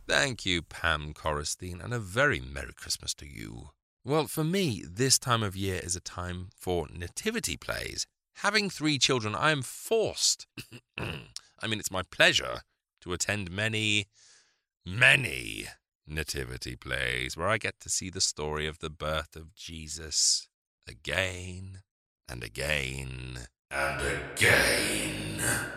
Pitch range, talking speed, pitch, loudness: 75-110 Hz, 135 wpm, 90 Hz, -29 LUFS